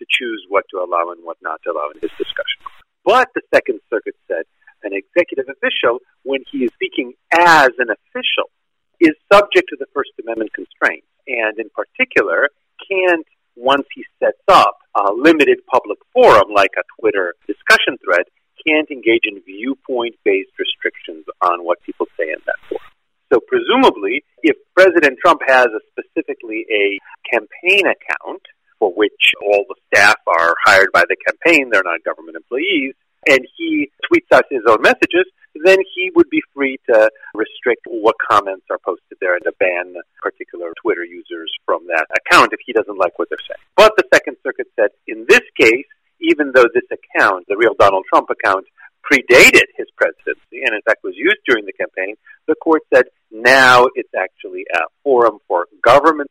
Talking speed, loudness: 175 wpm, -14 LUFS